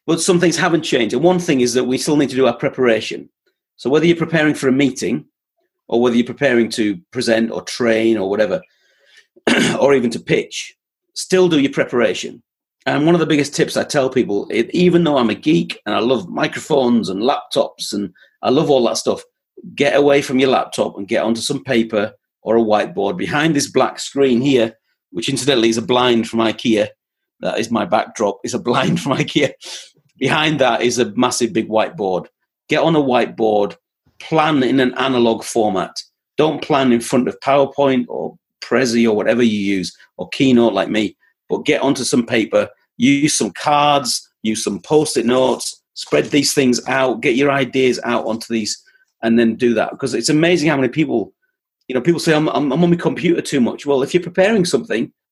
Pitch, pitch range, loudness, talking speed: 135 Hz, 120-160 Hz, -17 LUFS, 195 wpm